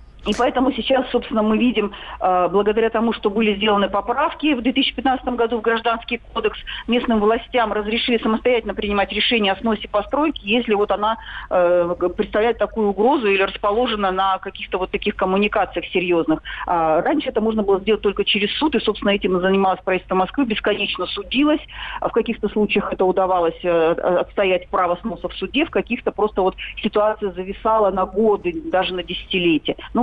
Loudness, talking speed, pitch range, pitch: -19 LUFS, 155 wpm, 190-230 Hz, 210 Hz